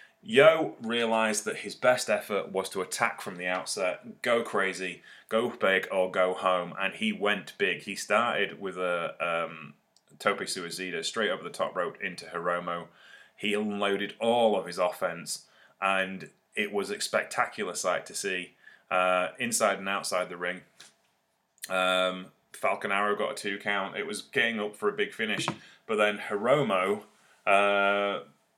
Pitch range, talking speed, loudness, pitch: 90-105 Hz, 160 wpm, -29 LUFS, 100 Hz